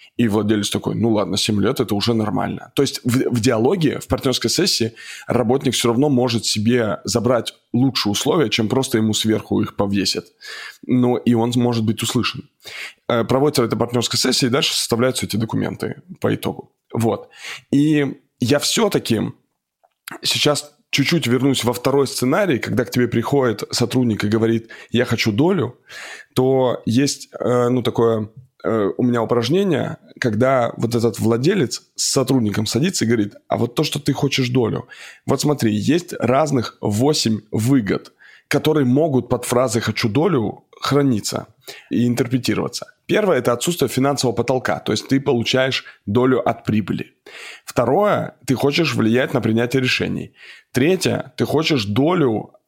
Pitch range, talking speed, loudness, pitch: 115-135 Hz, 150 wpm, -19 LUFS, 125 Hz